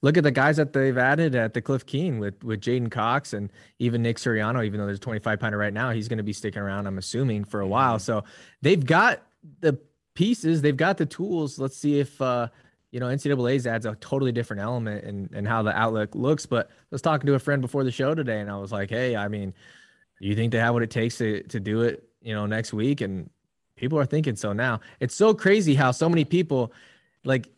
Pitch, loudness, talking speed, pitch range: 120 Hz, -25 LUFS, 240 wpm, 110-140 Hz